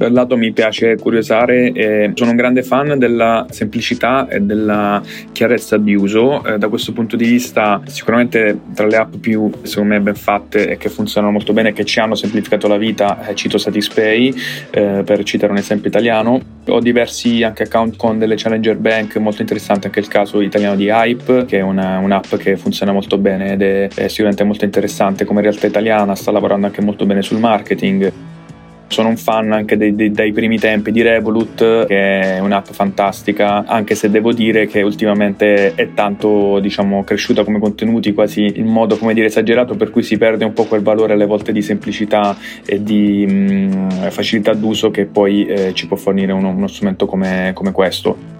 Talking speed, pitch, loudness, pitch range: 185 wpm, 105 Hz, -14 LUFS, 100-110 Hz